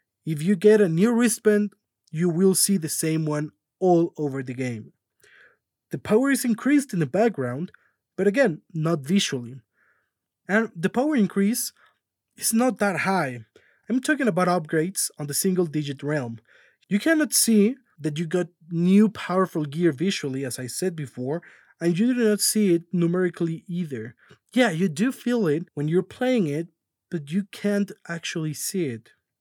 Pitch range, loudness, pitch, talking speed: 155-210 Hz, -23 LUFS, 180 Hz, 165 wpm